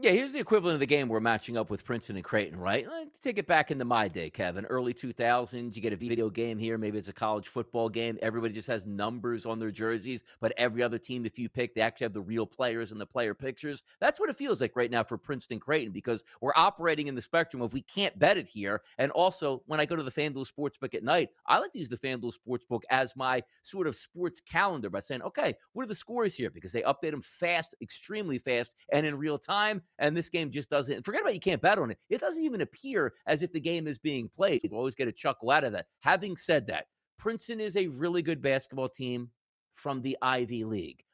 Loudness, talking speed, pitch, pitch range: -31 LUFS, 255 wpm, 130 Hz, 115-155 Hz